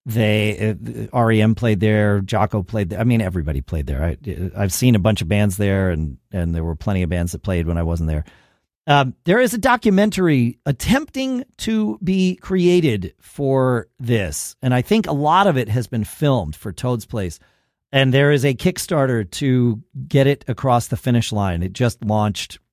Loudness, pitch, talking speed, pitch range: -19 LUFS, 115 Hz, 195 wpm, 95-140 Hz